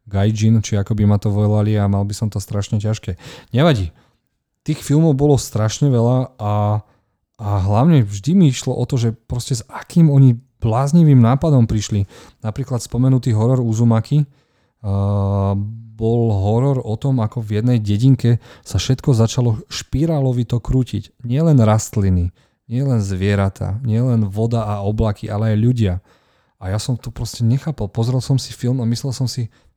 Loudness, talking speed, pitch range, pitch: -18 LUFS, 160 wpm, 105-130 Hz, 115 Hz